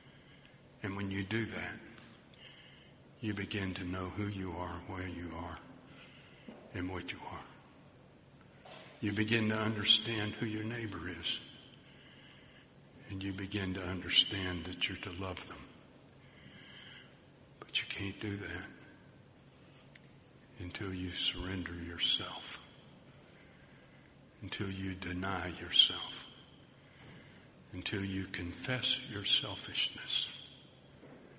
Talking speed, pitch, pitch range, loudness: 105 wpm, 100 Hz, 90-115 Hz, -35 LUFS